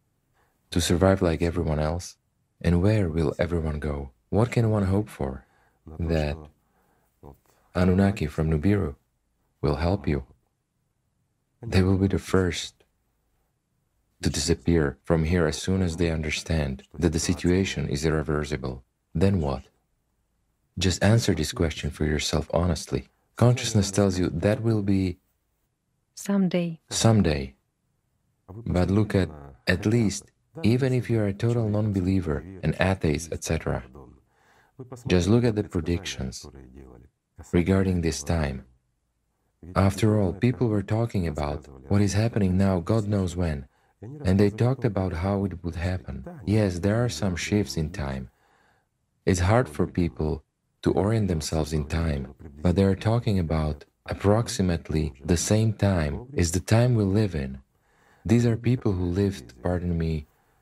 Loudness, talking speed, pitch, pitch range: -25 LUFS, 140 wpm, 90 Hz, 80-105 Hz